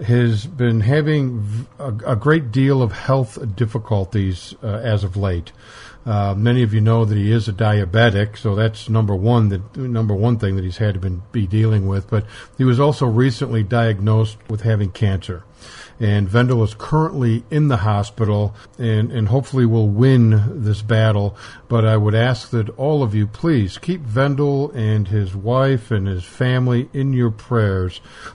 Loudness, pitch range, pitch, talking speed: -18 LUFS, 105-125 Hz, 110 Hz, 180 wpm